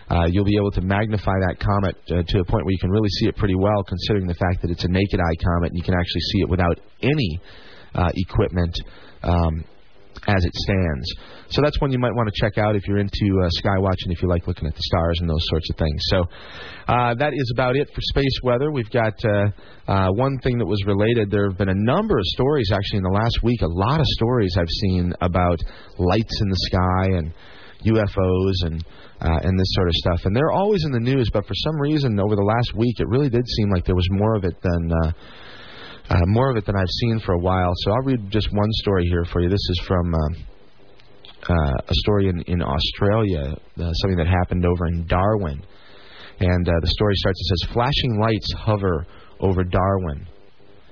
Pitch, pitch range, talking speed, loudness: 95 Hz, 90-105 Hz, 230 wpm, -21 LUFS